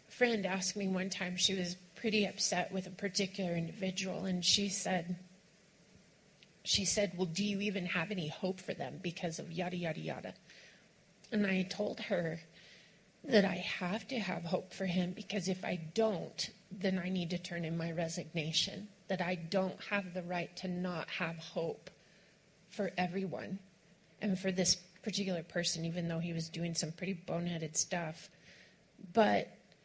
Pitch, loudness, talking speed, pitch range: 185 Hz, -36 LUFS, 165 wpm, 175-195 Hz